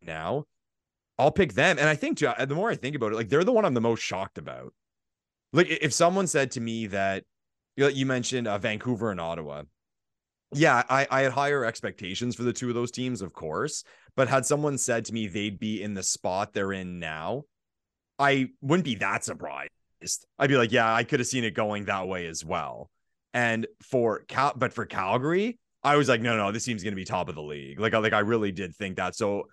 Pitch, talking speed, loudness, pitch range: 115 Hz, 225 wpm, -27 LUFS, 95-135 Hz